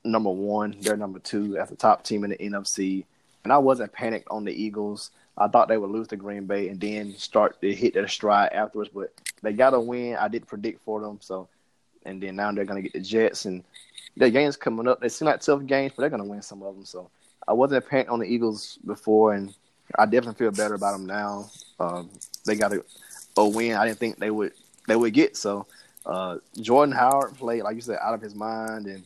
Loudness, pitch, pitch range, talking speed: -25 LUFS, 105 Hz, 100-115 Hz, 240 wpm